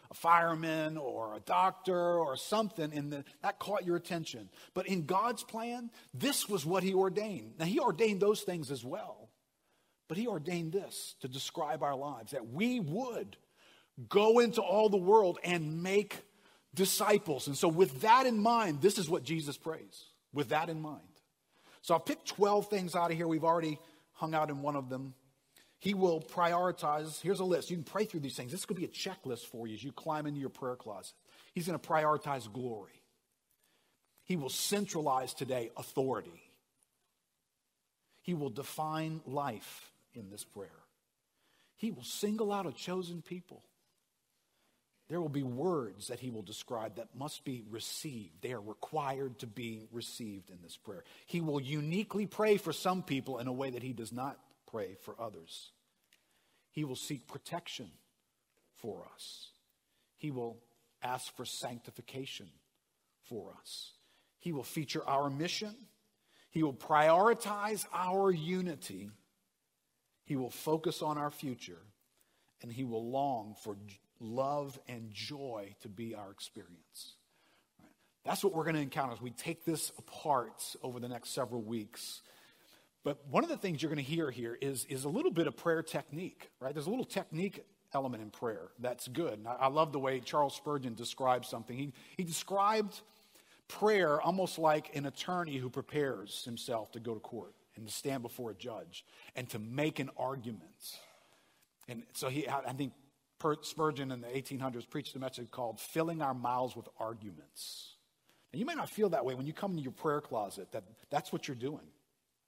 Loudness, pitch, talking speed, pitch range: -36 LUFS, 150 Hz, 175 wpm, 125-180 Hz